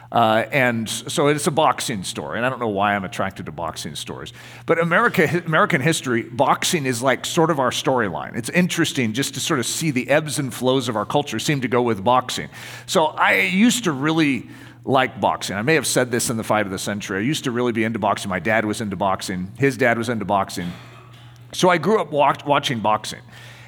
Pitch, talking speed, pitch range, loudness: 125 Hz, 225 wpm, 115-150 Hz, -20 LUFS